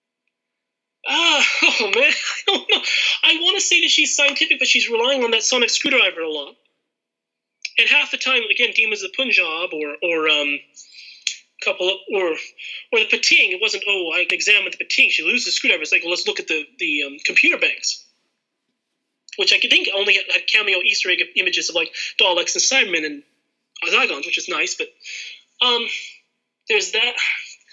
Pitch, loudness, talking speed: 245 Hz, -17 LUFS, 180 wpm